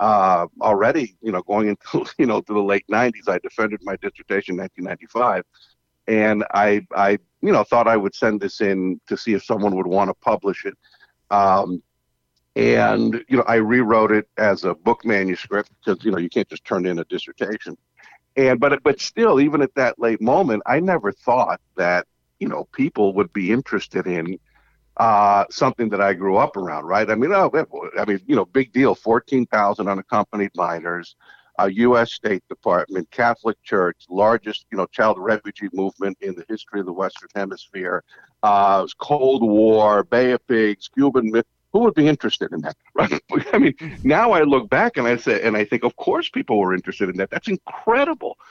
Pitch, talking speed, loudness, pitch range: 105 Hz, 190 wpm, -20 LUFS, 100-120 Hz